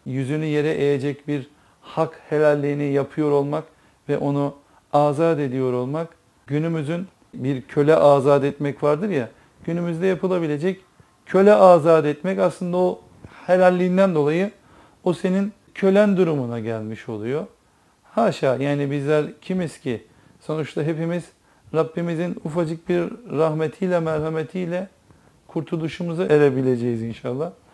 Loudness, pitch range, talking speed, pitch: -21 LUFS, 145-180 Hz, 110 wpm, 155 Hz